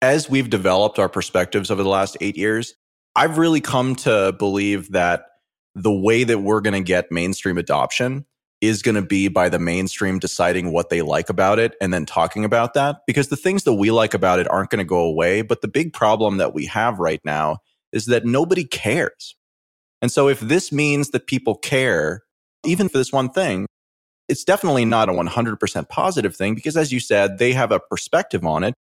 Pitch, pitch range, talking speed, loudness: 110 Hz, 95-130 Hz, 205 wpm, -19 LUFS